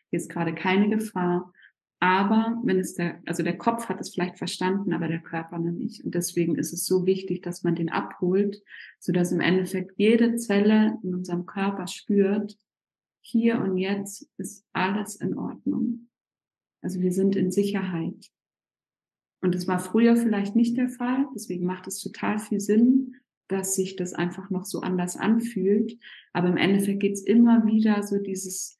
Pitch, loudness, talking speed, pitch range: 190 Hz, -25 LUFS, 175 wpm, 180-215 Hz